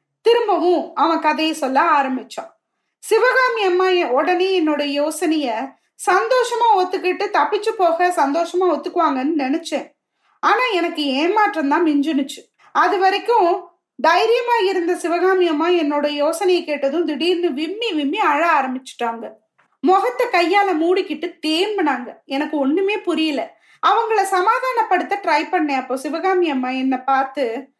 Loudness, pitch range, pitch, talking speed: -18 LUFS, 300-390 Hz, 345 Hz, 110 wpm